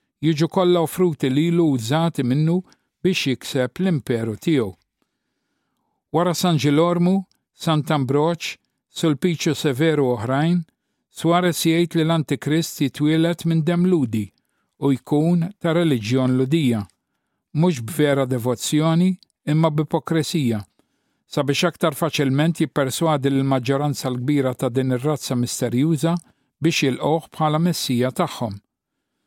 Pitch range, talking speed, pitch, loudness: 135-165 Hz, 115 wpm, 155 Hz, -21 LUFS